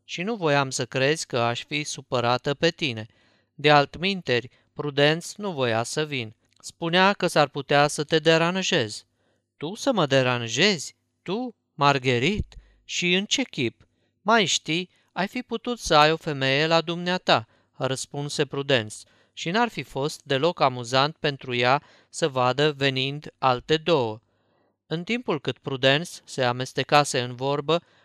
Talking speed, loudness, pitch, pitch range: 150 wpm, -24 LUFS, 145 Hz, 125-165 Hz